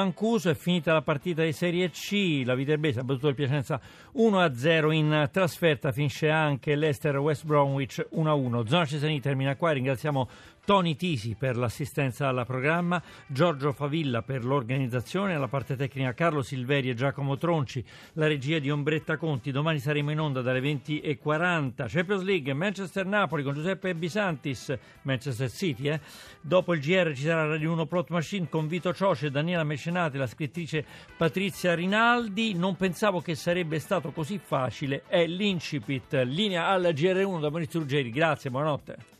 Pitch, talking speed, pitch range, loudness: 155 Hz, 155 wpm, 140-175 Hz, -27 LUFS